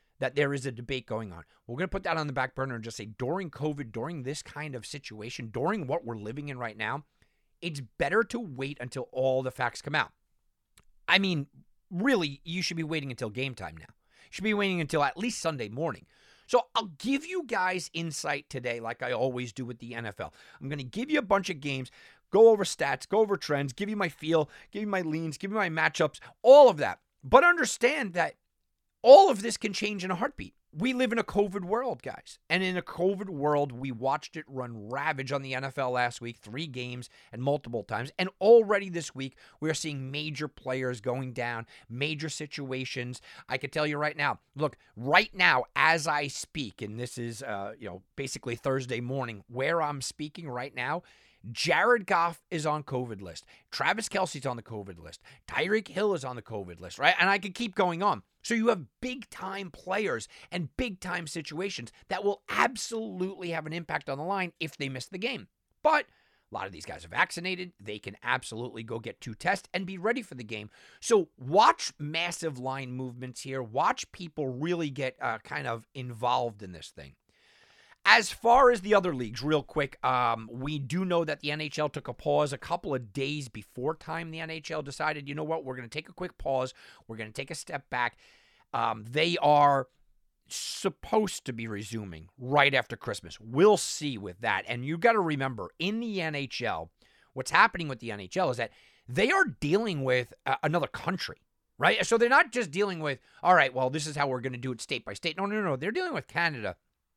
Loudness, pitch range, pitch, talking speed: -29 LUFS, 125-185 Hz, 145 Hz, 215 wpm